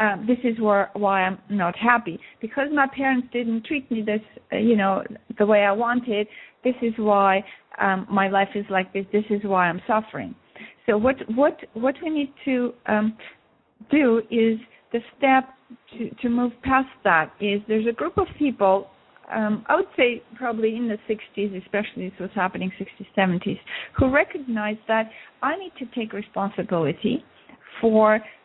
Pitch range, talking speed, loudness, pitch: 205-250 Hz, 175 wpm, -23 LUFS, 220 Hz